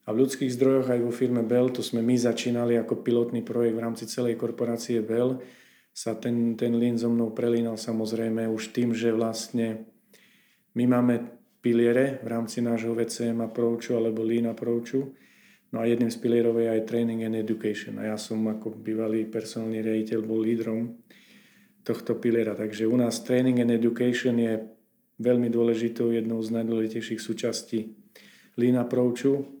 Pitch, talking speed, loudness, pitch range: 115 Hz, 165 wpm, -27 LUFS, 115-120 Hz